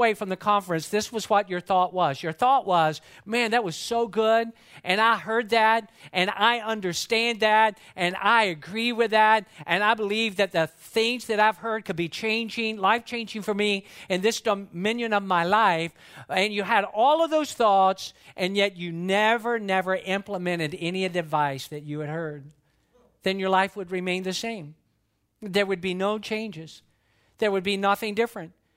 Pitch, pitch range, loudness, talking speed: 200 Hz, 175-225 Hz, -24 LUFS, 185 wpm